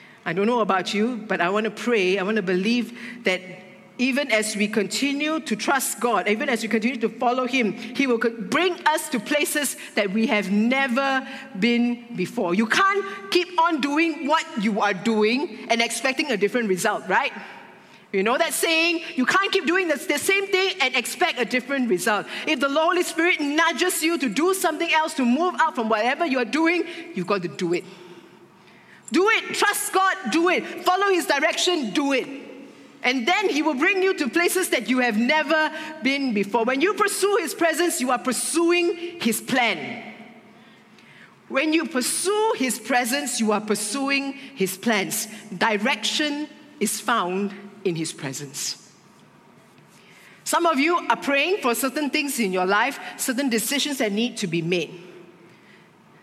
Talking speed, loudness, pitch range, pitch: 175 wpm, -22 LUFS, 220-320 Hz, 255 Hz